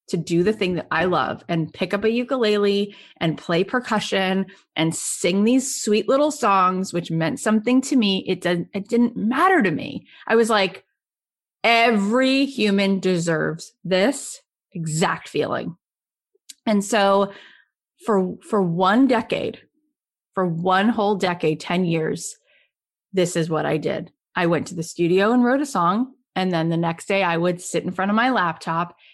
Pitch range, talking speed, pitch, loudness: 175-230 Hz, 165 wpm, 195 Hz, -21 LUFS